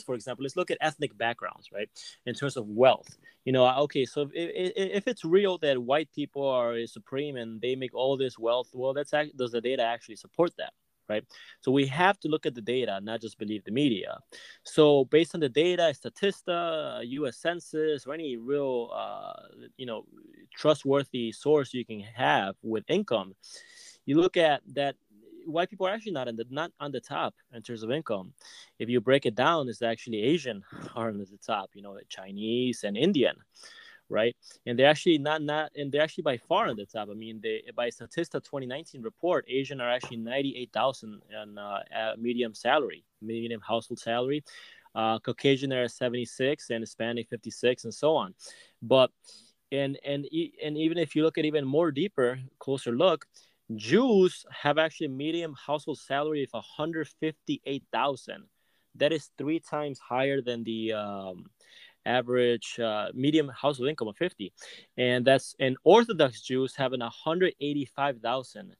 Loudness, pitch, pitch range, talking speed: -29 LUFS, 135 Hz, 120-155 Hz, 180 wpm